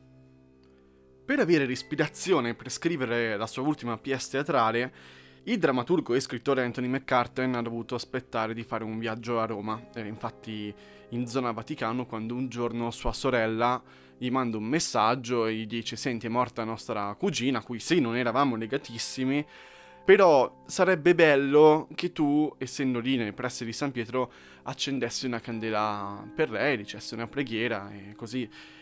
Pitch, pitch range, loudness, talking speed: 120 Hz, 110-135 Hz, -28 LUFS, 160 wpm